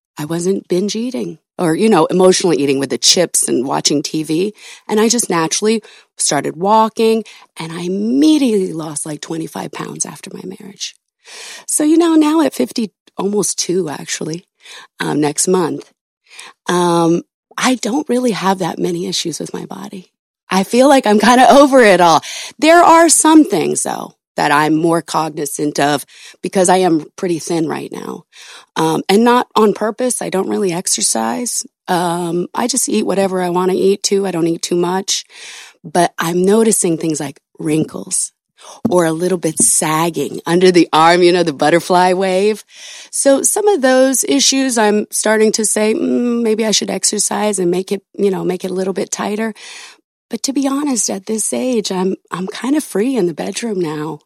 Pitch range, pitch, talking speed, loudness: 170-225 Hz, 190 Hz, 180 wpm, -14 LUFS